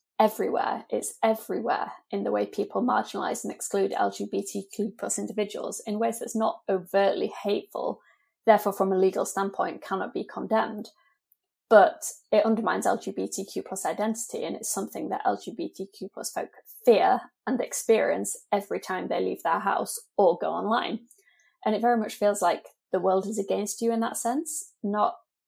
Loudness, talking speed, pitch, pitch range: -27 LUFS, 160 wpm, 215 Hz, 200-235 Hz